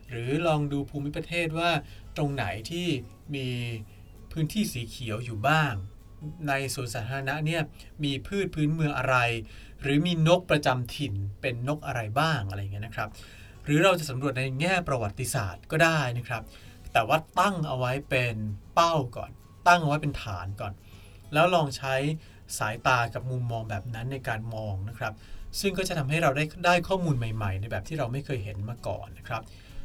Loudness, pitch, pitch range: -28 LUFS, 130 Hz, 105-150 Hz